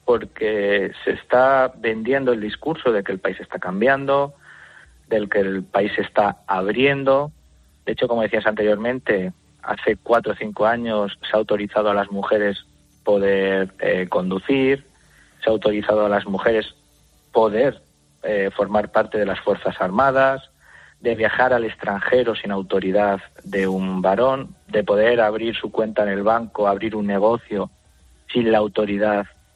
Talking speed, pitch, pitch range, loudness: 150 wpm, 105 Hz, 100-120 Hz, -20 LUFS